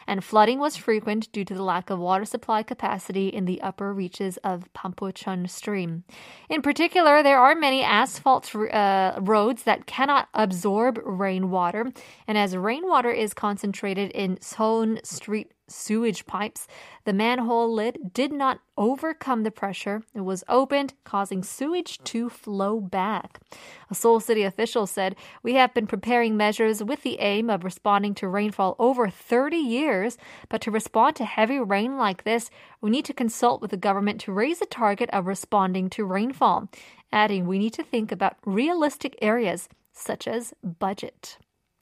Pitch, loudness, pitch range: 215 Hz, -24 LUFS, 200-240 Hz